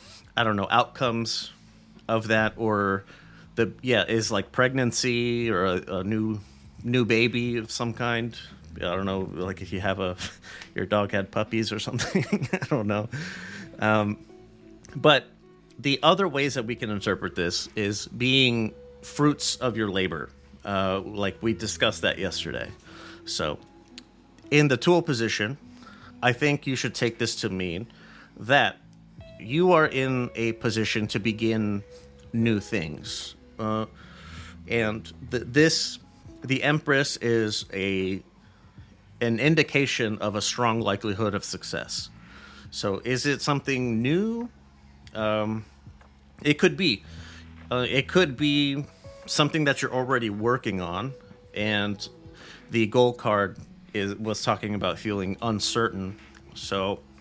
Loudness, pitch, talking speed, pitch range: -26 LUFS, 110 Hz, 135 wpm, 100-125 Hz